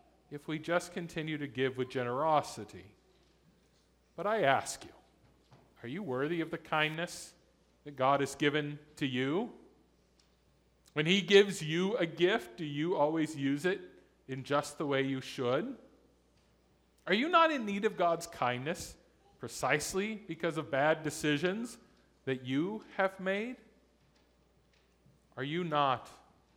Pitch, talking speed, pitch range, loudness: 155 Hz, 140 wpm, 135-180 Hz, -33 LUFS